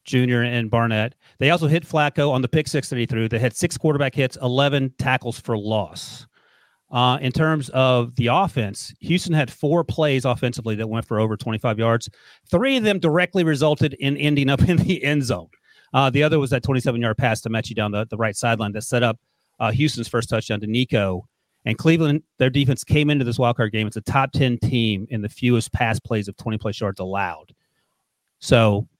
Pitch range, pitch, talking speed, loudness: 110-145 Hz, 125 Hz, 210 wpm, -21 LUFS